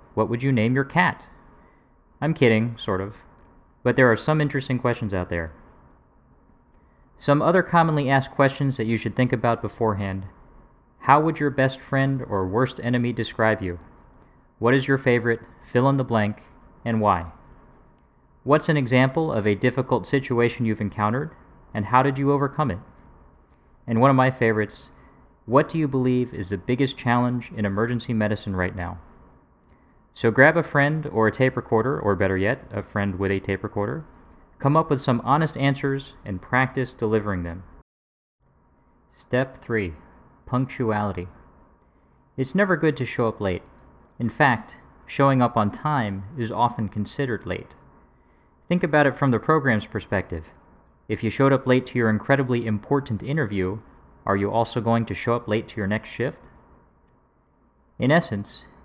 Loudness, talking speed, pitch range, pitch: -23 LUFS, 165 wpm, 95-135 Hz, 115 Hz